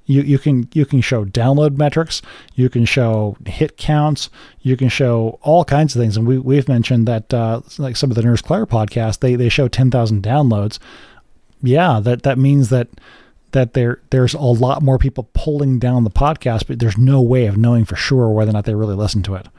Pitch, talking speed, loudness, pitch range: 125 Hz, 215 wpm, -16 LUFS, 115-140 Hz